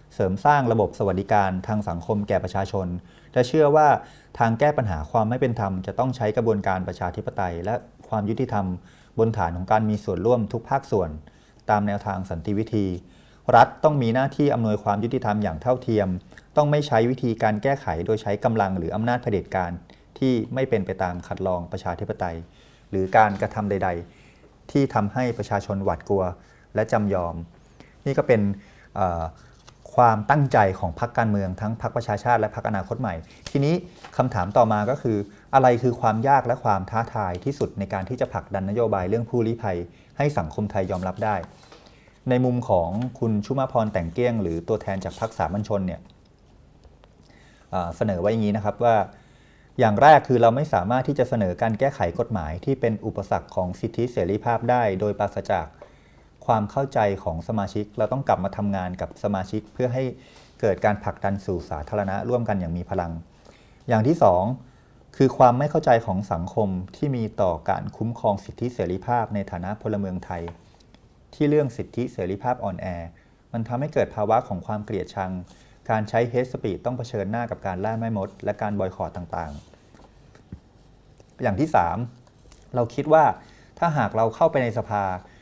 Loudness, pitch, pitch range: -24 LUFS, 105 Hz, 95-120 Hz